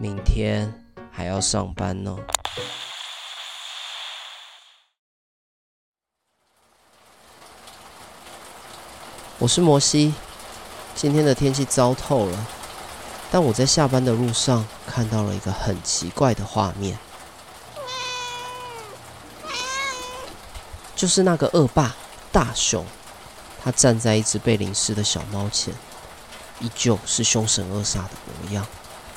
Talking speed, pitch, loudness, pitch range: 140 characters per minute, 115 Hz, -22 LUFS, 100-140 Hz